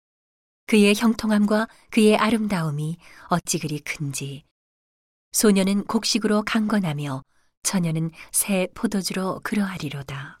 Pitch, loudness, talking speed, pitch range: 190 Hz, -22 LUFS, 255 characters per minute, 155-215 Hz